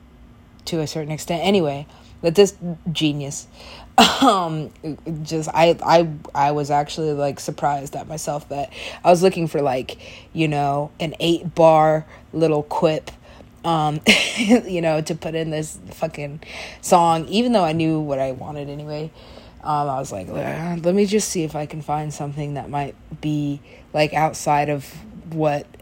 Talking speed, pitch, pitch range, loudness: 160 wpm, 155 Hz, 145-165 Hz, -20 LUFS